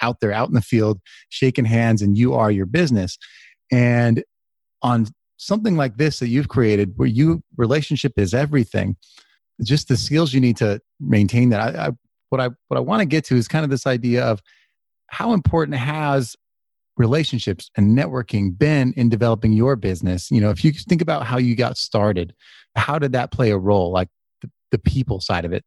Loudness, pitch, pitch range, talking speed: -19 LUFS, 120 Hz, 105-140 Hz, 195 wpm